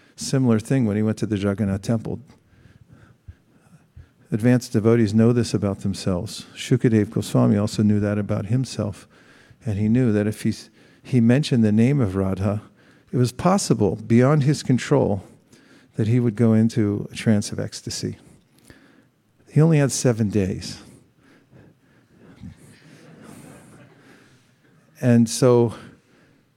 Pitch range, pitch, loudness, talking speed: 105-125 Hz, 115 Hz, -21 LUFS, 125 wpm